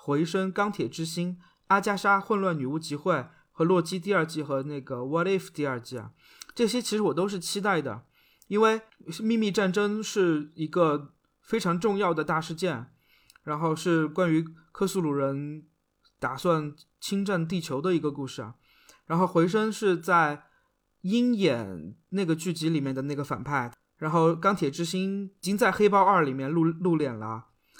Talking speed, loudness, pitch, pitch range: 255 characters per minute, -27 LUFS, 170 Hz, 150-195 Hz